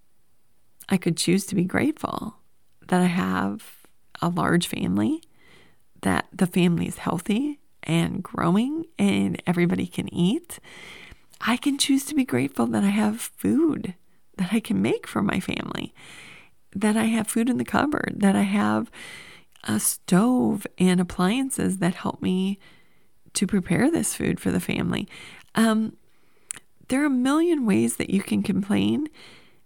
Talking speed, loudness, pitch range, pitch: 150 wpm, -24 LUFS, 175-245 Hz, 200 Hz